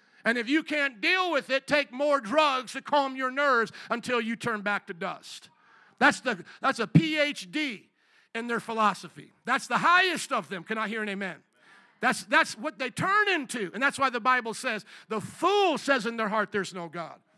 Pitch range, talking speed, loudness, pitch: 220-290 Hz, 205 wpm, -27 LUFS, 250 Hz